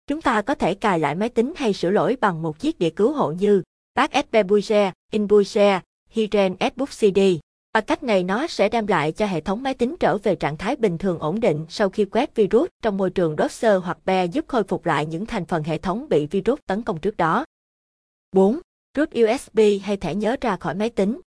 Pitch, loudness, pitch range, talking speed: 210 Hz, -21 LUFS, 185-230 Hz, 220 wpm